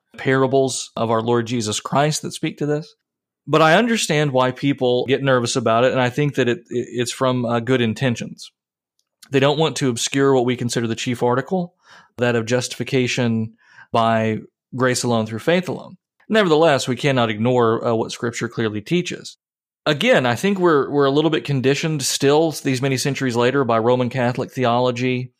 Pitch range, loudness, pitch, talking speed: 120-145 Hz, -19 LUFS, 130 Hz, 180 wpm